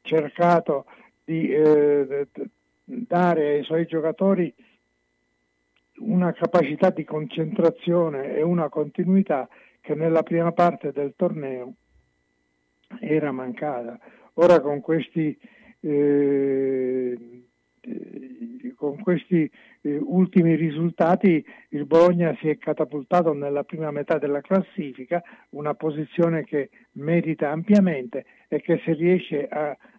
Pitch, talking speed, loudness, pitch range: 155 Hz, 100 wpm, -23 LUFS, 145-175 Hz